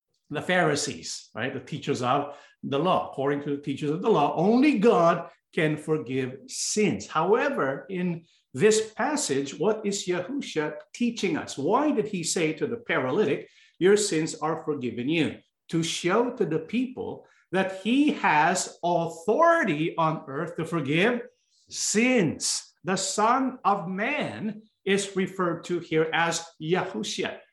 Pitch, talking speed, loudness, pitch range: 175 Hz, 140 wpm, -26 LUFS, 155-215 Hz